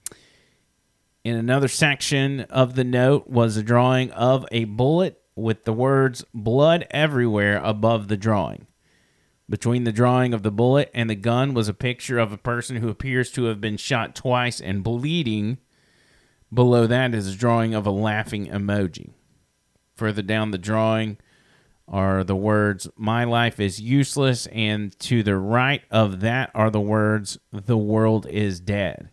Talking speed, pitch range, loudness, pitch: 160 wpm, 105-125 Hz, -22 LUFS, 115 Hz